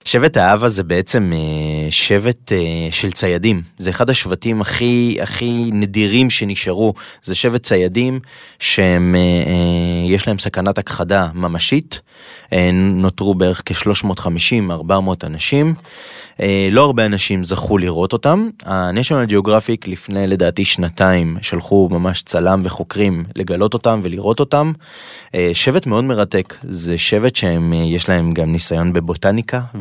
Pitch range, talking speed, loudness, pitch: 90-110 Hz, 110 wpm, -15 LUFS, 95 Hz